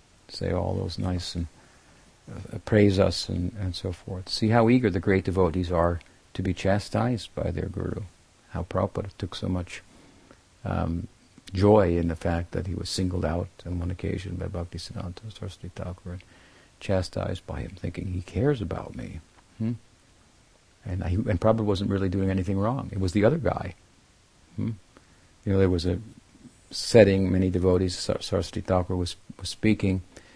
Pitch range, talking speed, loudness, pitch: 90-105 Hz, 170 wpm, -27 LUFS, 95 Hz